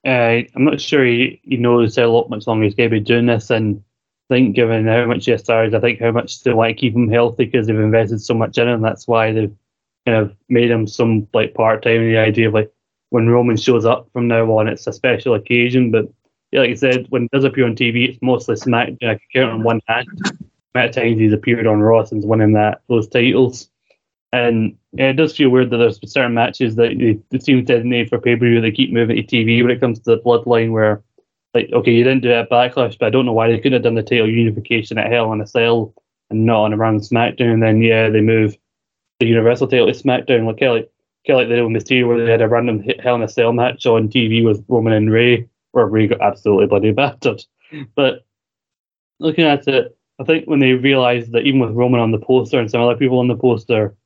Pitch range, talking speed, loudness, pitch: 110-125 Hz, 250 wpm, -15 LUFS, 120 Hz